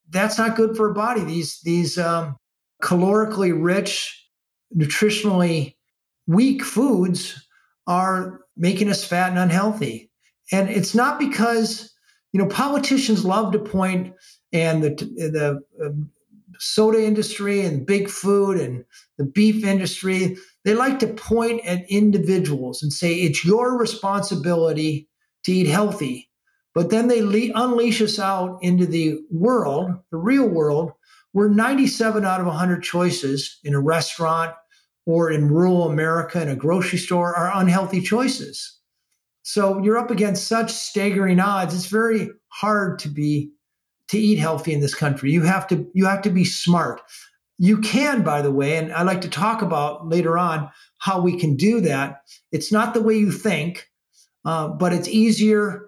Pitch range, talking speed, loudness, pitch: 165-215 Hz, 150 wpm, -20 LUFS, 185 Hz